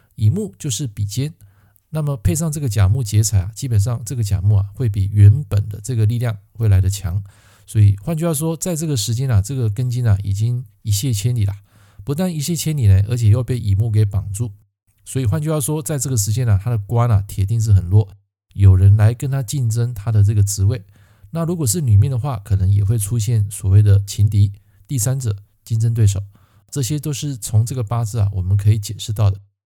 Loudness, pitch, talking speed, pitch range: -18 LUFS, 110 Hz, 320 characters per minute, 100-125 Hz